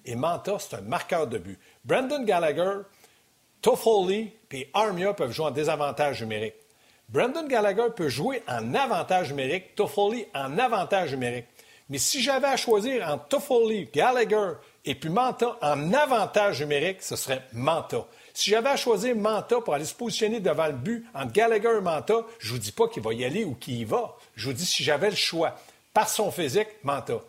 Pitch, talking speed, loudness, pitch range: 200 Hz, 185 wpm, -26 LUFS, 145-225 Hz